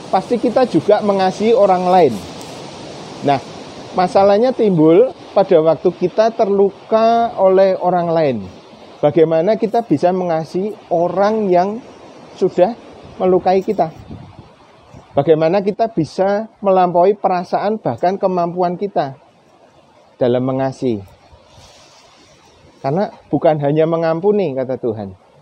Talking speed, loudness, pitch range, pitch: 95 wpm, -15 LUFS, 160-205 Hz, 185 Hz